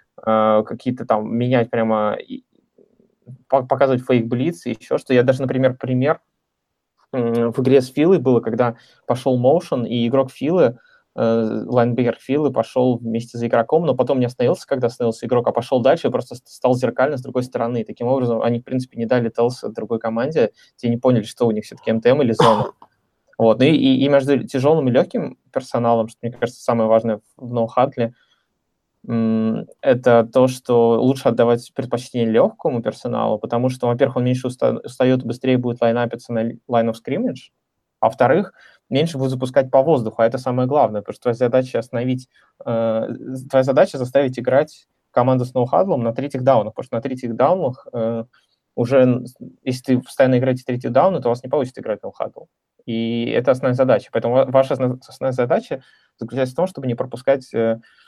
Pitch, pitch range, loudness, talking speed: 125 Hz, 115-130 Hz, -19 LUFS, 175 wpm